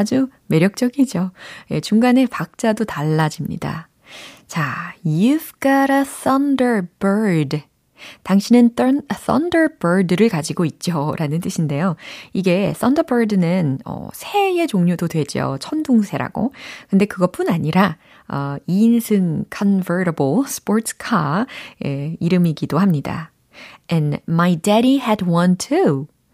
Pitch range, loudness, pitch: 165-240 Hz, -18 LUFS, 195 Hz